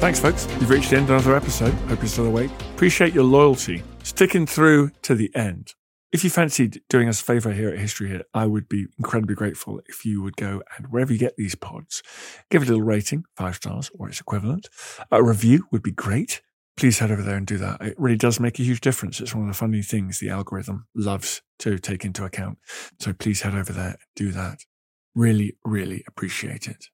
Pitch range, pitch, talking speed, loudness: 100-125 Hz, 110 Hz, 225 wpm, -22 LUFS